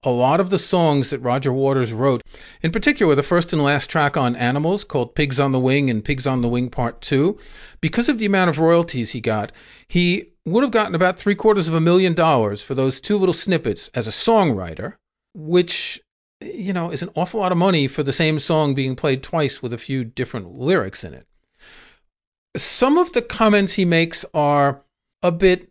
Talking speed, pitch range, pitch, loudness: 210 wpm, 135-185 Hz, 155 Hz, -19 LUFS